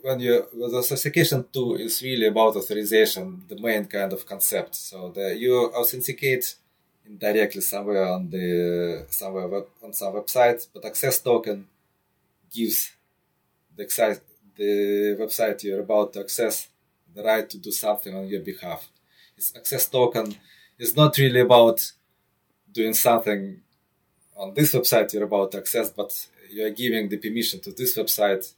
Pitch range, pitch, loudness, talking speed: 100-125 Hz, 110 Hz, -23 LUFS, 150 wpm